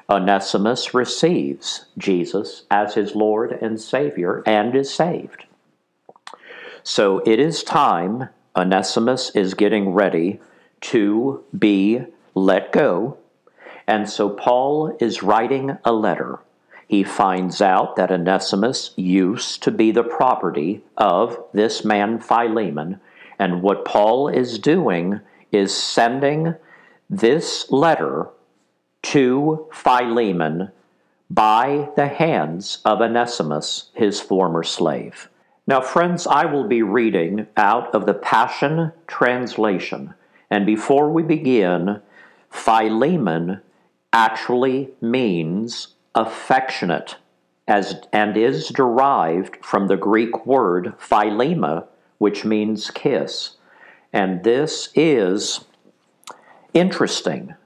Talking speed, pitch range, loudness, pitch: 100 wpm, 95-125 Hz, -19 LUFS, 110 Hz